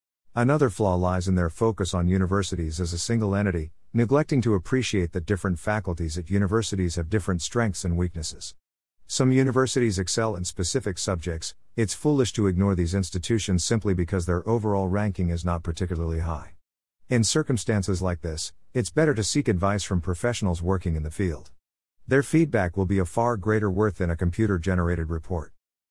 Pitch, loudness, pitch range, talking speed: 95 Hz, -25 LUFS, 90-110 Hz, 170 wpm